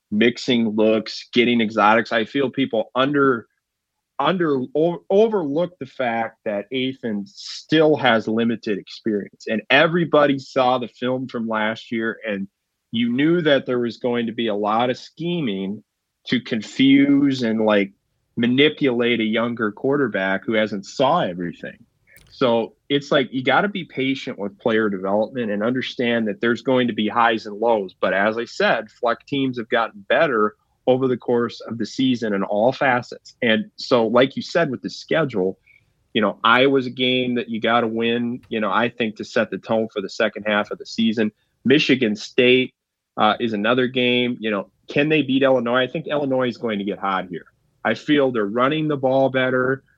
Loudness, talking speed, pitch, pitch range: -20 LUFS, 180 wpm, 120 Hz, 110-135 Hz